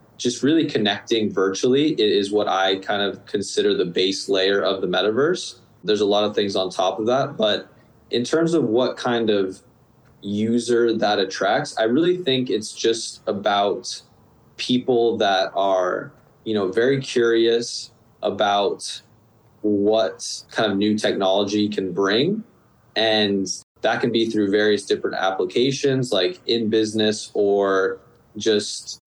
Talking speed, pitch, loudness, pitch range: 140 wpm, 110 Hz, -21 LUFS, 100-120 Hz